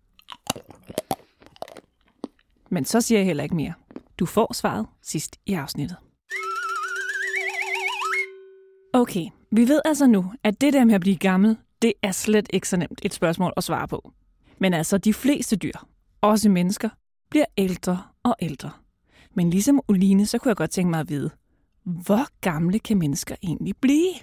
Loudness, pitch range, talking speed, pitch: -23 LUFS, 185-255 Hz, 160 wpm, 210 Hz